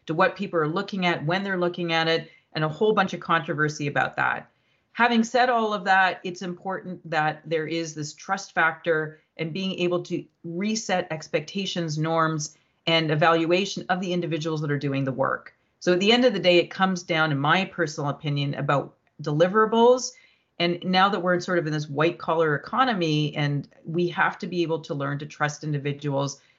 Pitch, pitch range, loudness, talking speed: 170 Hz, 155-185 Hz, -24 LUFS, 200 wpm